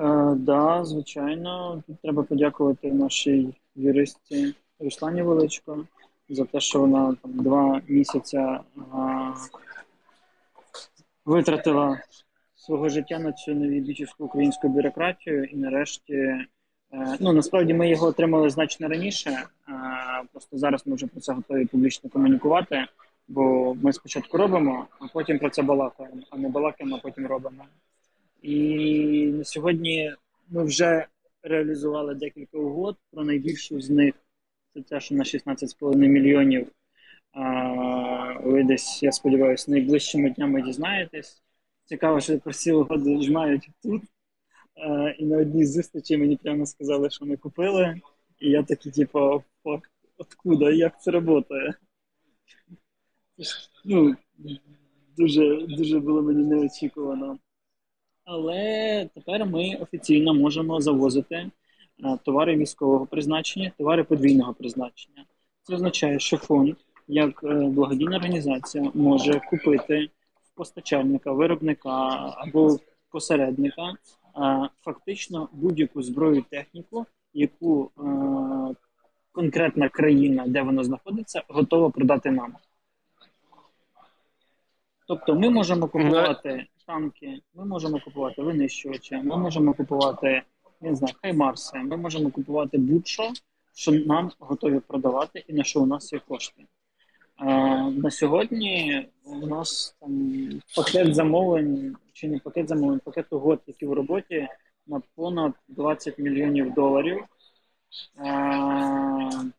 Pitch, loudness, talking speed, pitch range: 150 Hz, -24 LUFS, 115 wpm, 140-165 Hz